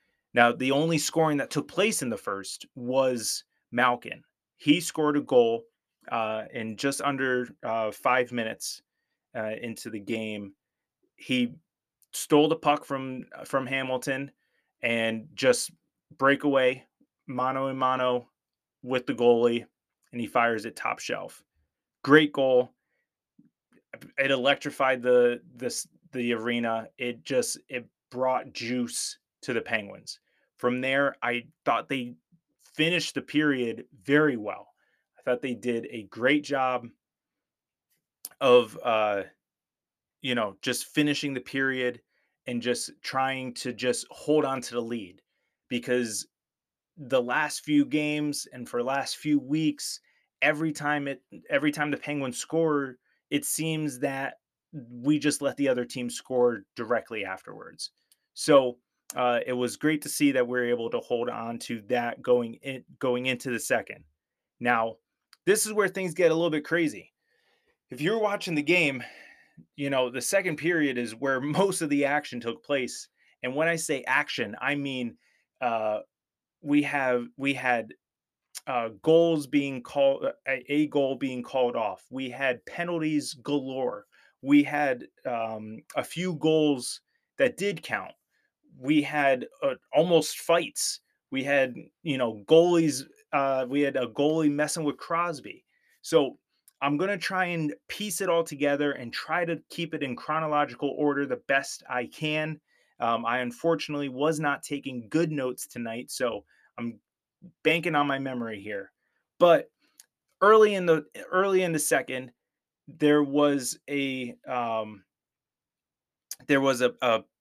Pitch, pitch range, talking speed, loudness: 140 Hz, 125-155 Hz, 145 wpm, -27 LUFS